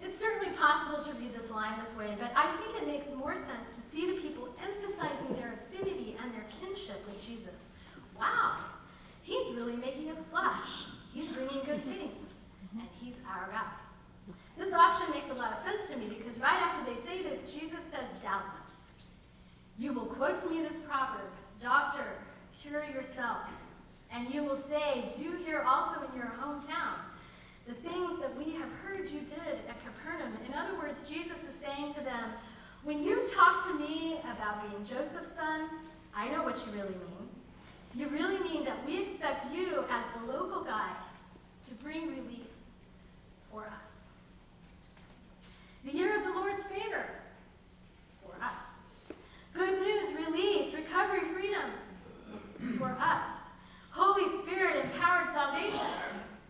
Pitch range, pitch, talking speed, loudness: 245-345 Hz, 295 Hz, 155 wpm, -35 LUFS